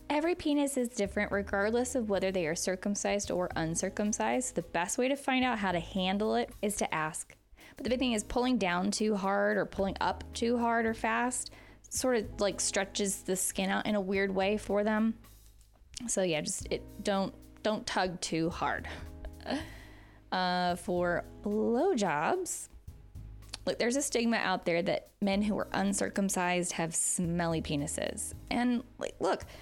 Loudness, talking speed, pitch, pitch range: -32 LUFS, 170 wpm, 200 Hz, 180-230 Hz